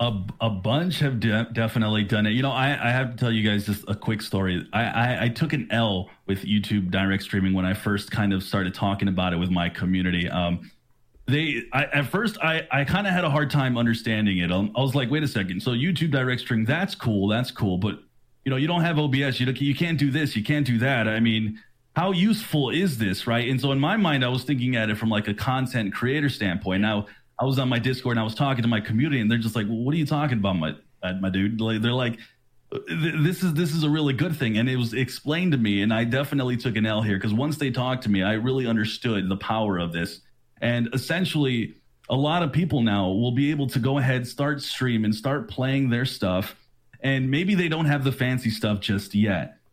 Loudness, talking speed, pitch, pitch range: -24 LUFS, 245 wpm, 120 Hz, 105-140 Hz